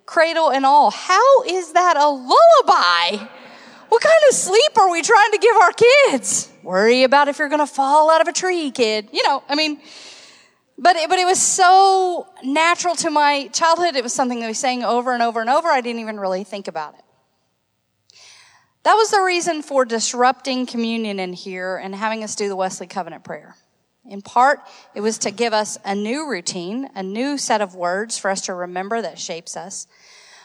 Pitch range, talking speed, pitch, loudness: 215-335 Hz, 200 wpm, 260 Hz, -17 LUFS